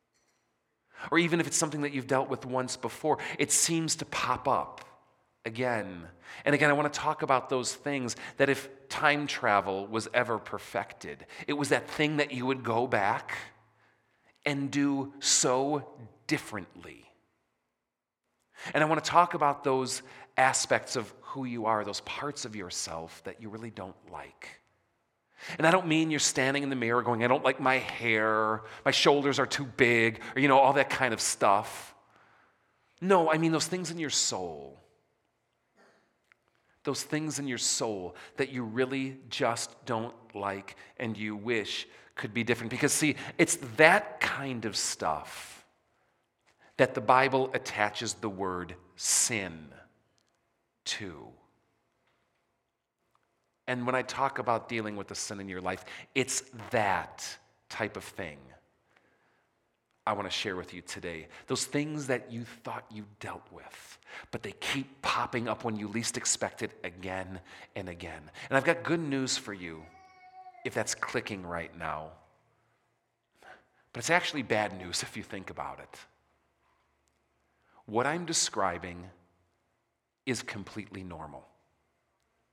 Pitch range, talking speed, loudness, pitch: 105-140 Hz, 150 wpm, -29 LUFS, 120 Hz